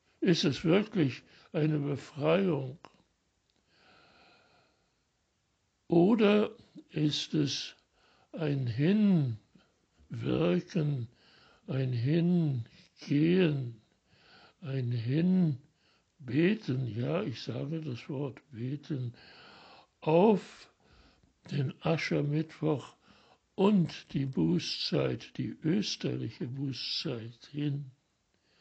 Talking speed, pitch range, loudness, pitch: 65 wpm, 130-170 Hz, -31 LUFS, 150 Hz